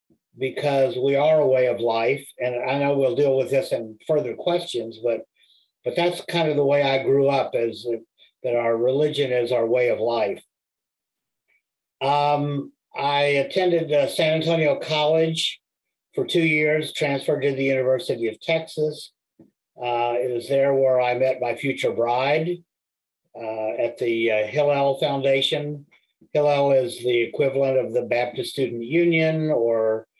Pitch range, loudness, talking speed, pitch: 125-155 Hz, -22 LUFS, 155 wpm, 140 Hz